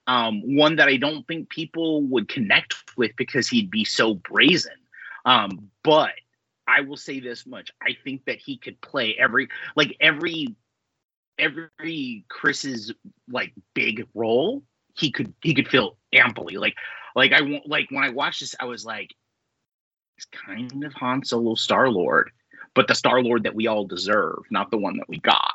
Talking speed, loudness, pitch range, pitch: 175 wpm, -22 LUFS, 120-165 Hz, 145 Hz